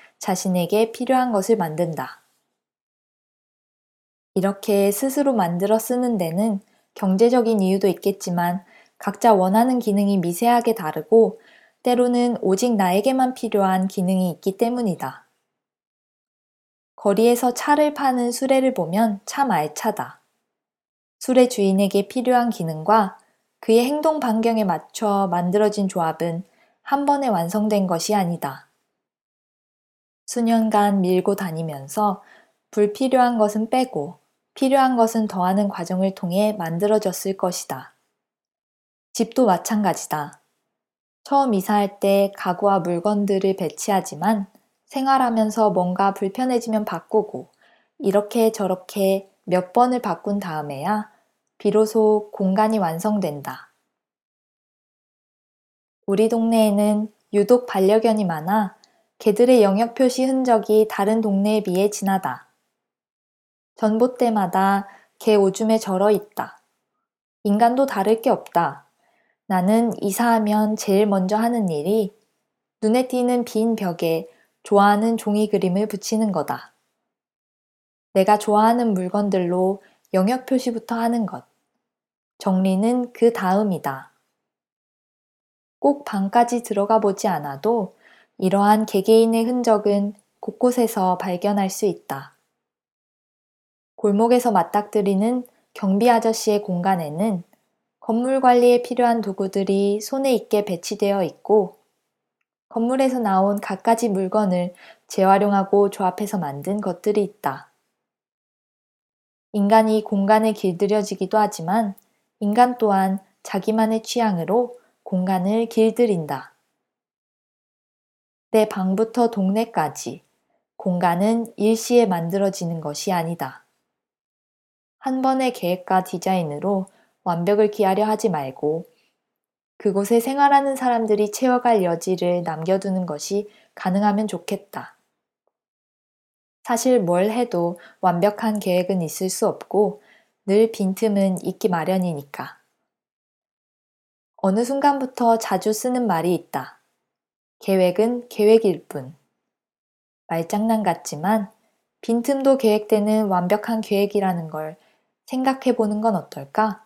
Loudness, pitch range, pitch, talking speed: -20 LUFS, 190-230 Hz, 210 Hz, 245 characters per minute